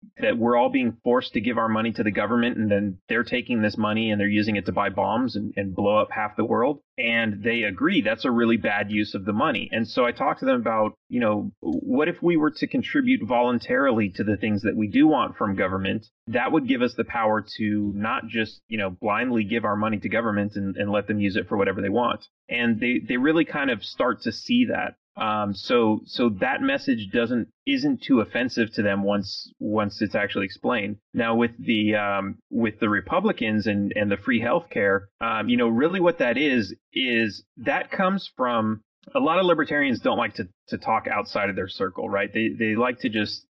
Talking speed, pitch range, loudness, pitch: 225 wpm, 105-170 Hz, -24 LUFS, 115 Hz